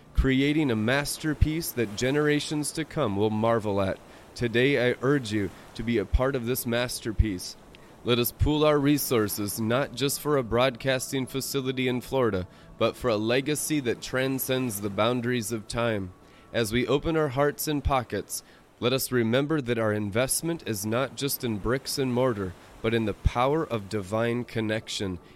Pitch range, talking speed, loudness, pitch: 110-135 Hz, 170 wpm, -27 LUFS, 120 Hz